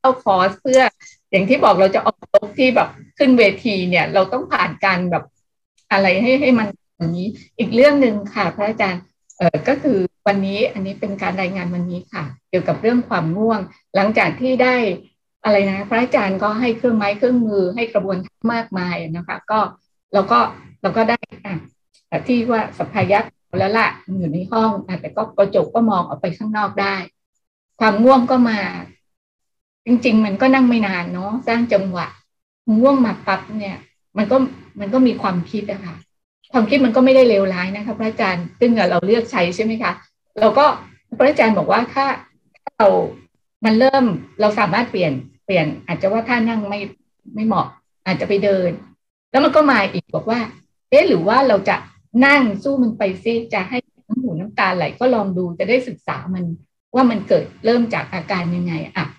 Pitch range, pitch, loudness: 190-240 Hz, 210 Hz, -17 LUFS